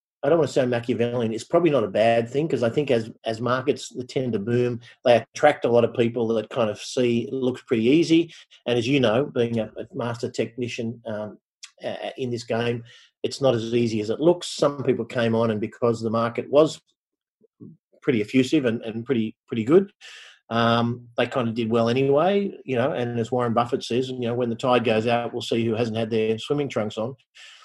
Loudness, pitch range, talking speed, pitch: -23 LUFS, 115-130 Hz, 220 wpm, 120 Hz